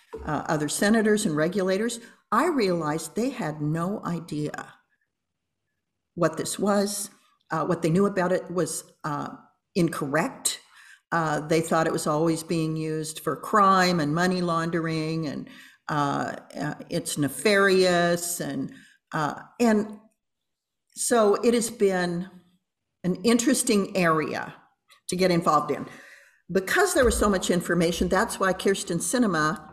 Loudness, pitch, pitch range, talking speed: -25 LUFS, 180 Hz, 160-205 Hz, 130 wpm